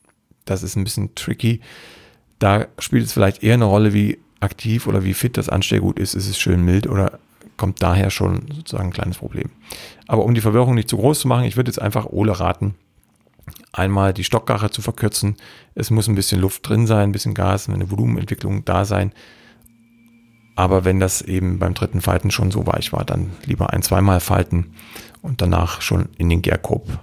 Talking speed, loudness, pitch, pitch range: 195 wpm, -19 LUFS, 105 Hz, 95-115 Hz